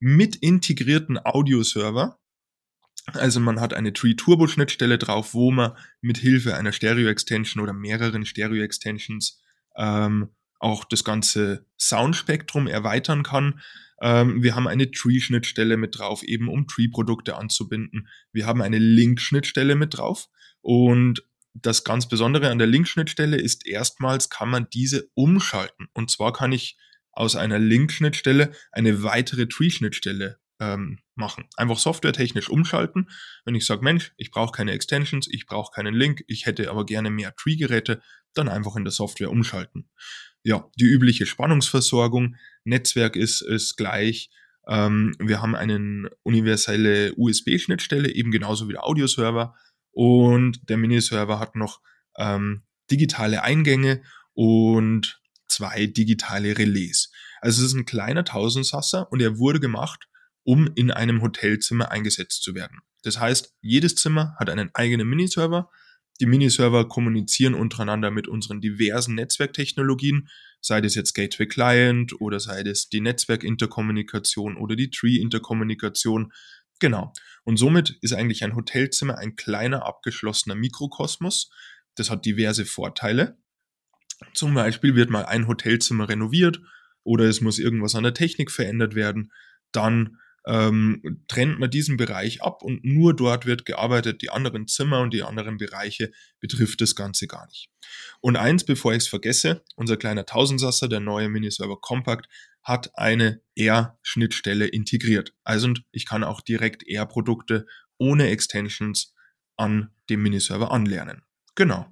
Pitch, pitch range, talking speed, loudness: 115 Hz, 110-130 Hz, 145 wpm, -22 LUFS